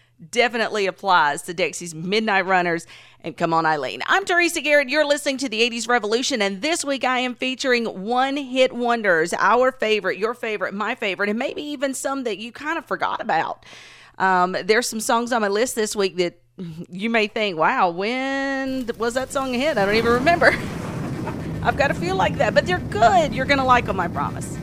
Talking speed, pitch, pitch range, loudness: 205 wpm, 230 Hz, 190-260 Hz, -21 LUFS